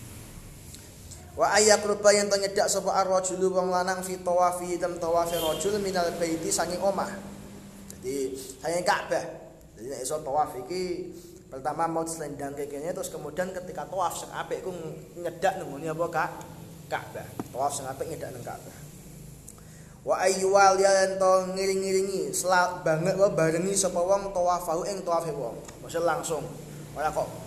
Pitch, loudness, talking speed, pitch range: 175 Hz, -27 LUFS, 165 wpm, 160-190 Hz